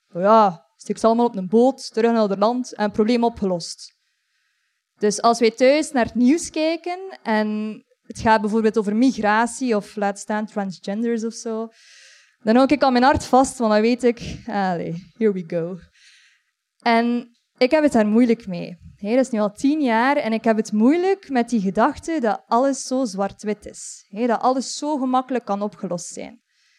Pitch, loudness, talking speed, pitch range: 230 Hz, -20 LUFS, 185 wpm, 210-255 Hz